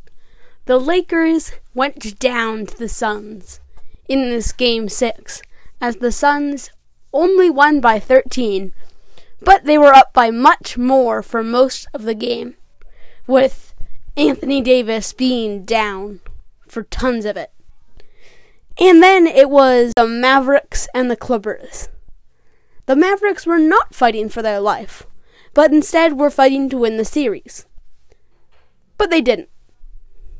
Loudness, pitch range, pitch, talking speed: -14 LUFS, 230-300 Hz, 255 Hz, 130 wpm